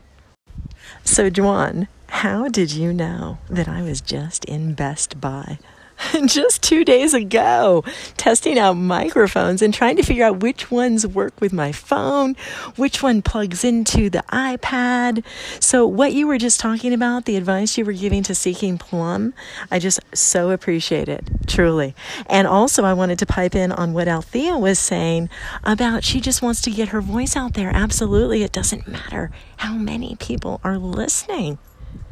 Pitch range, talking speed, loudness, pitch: 180-245 Hz, 165 wpm, -18 LUFS, 205 Hz